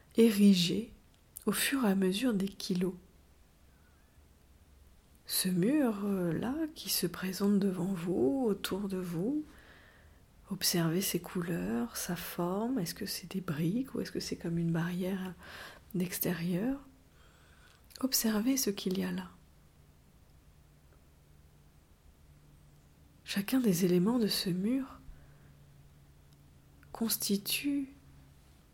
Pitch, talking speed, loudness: 180 Hz, 100 wpm, -32 LUFS